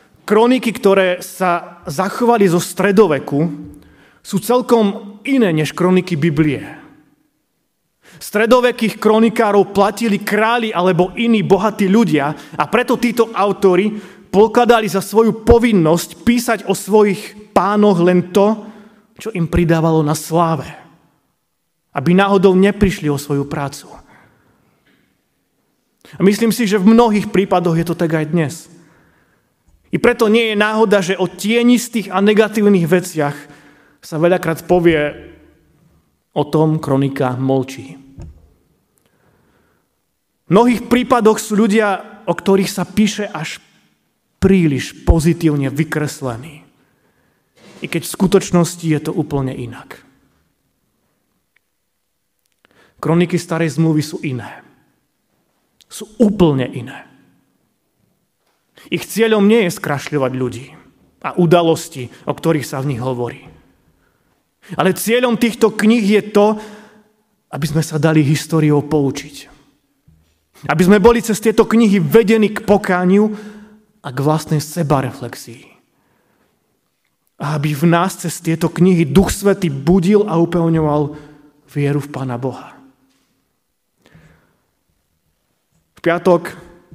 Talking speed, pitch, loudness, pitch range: 110 wpm, 180 Hz, -15 LUFS, 150-210 Hz